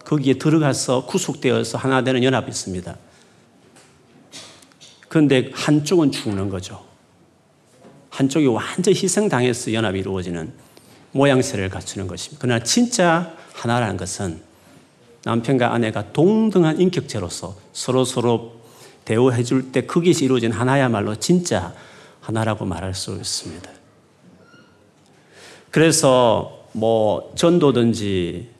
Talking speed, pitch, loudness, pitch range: 275 characters per minute, 125 Hz, -19 LUFS, 105-140 Hz